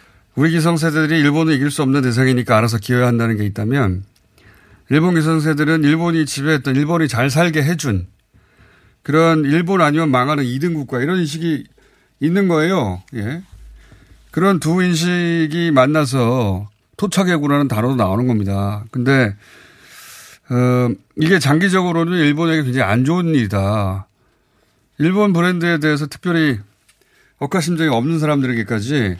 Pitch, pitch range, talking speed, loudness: 140 Hz, 110-160 Hz, 320 characters per minute, -16 LUFS